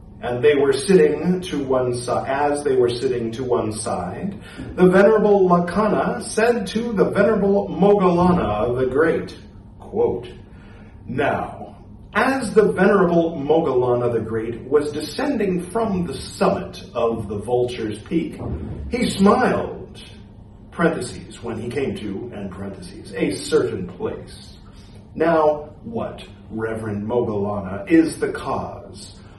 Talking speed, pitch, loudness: 125 wpm, 140 Hz, -20 LUFS